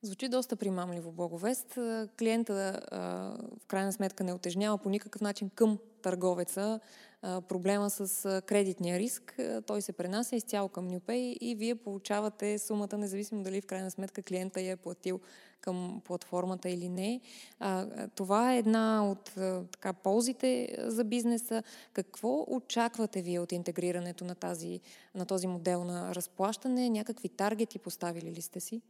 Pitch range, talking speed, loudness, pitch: 185-225 Hz, 140 wpm, -34 LUFS, 200 Hz